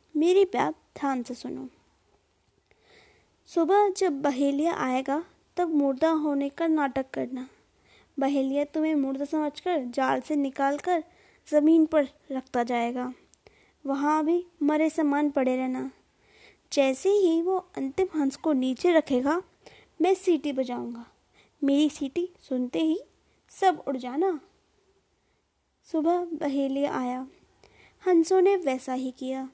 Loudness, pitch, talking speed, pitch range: -26 LUFS, 295 Hz, 120 wpm, 270-335 Hz